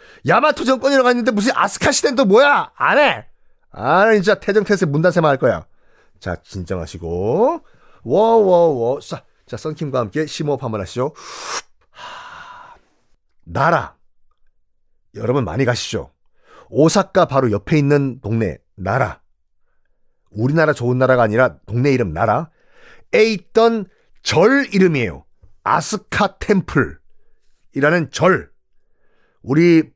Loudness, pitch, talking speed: -17 LUFS, 165 Hz, 250 characters per minute